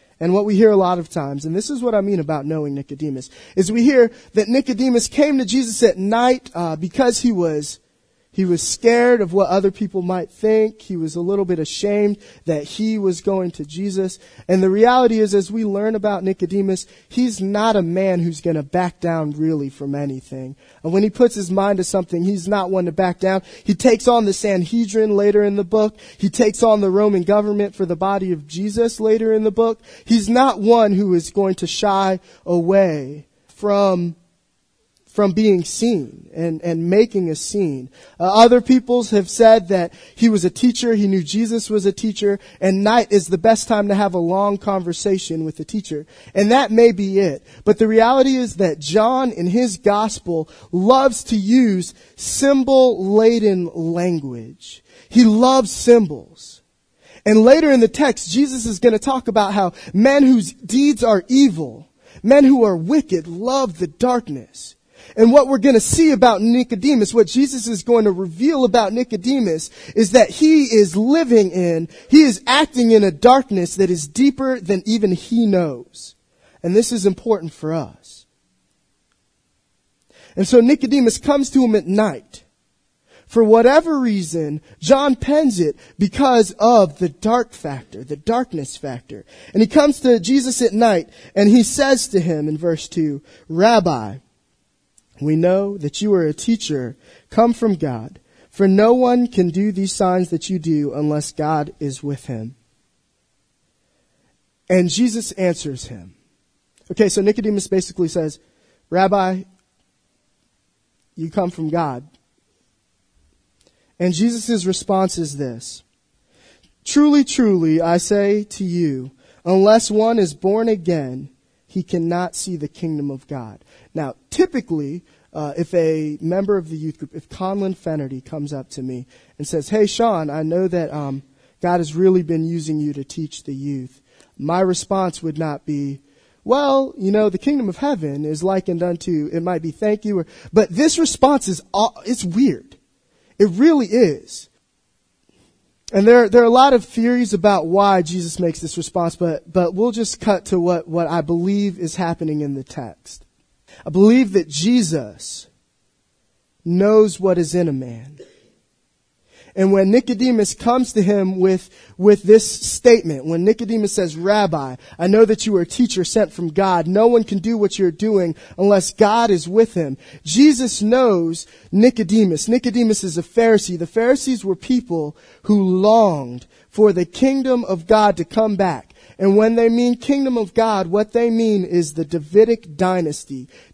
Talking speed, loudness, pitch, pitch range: 170 wpm, -17 LUFS, 195 Hz, 170-230 Hz